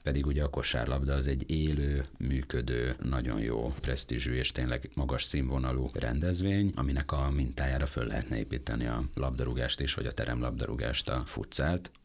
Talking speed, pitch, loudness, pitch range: 150 wpm, 65 Hz, -32 LUFS, 60-70 Hz